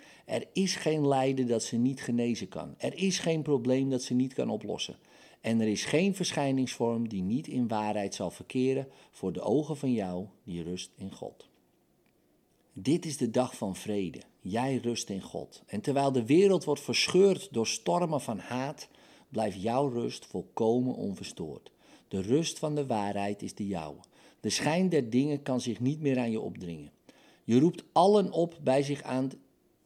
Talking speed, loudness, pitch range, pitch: 180 wpm, -30 LUFS, 110-145 Hz, 130 Hz